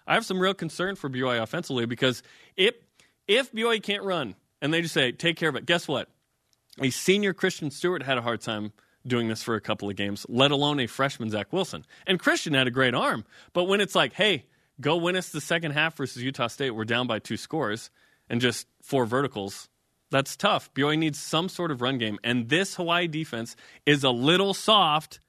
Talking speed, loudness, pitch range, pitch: 215 wpm, -26 LUFS, 120-175 Hz, 145 Hz